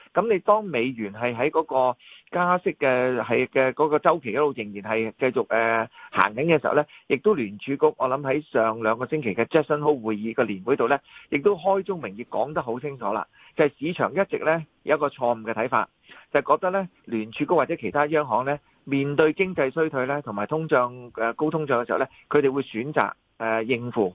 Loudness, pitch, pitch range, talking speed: -24 LUFS, 140 Hz, 115-155 Hz, 335 characters per minute